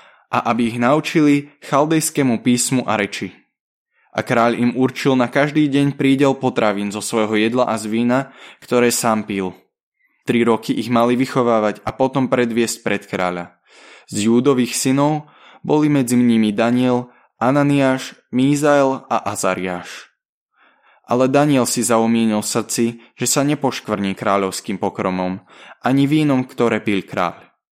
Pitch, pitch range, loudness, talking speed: 120 Hz, 110-135 Hz, -18 LUFS, 135 wpm